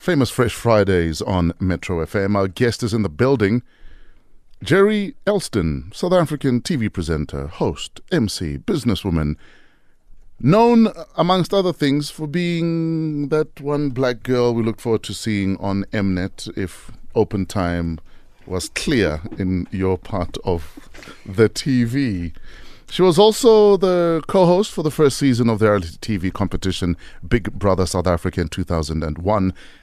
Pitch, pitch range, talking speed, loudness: 110 Hz, 95-150 Hz, 145 wpm, -19 LUFS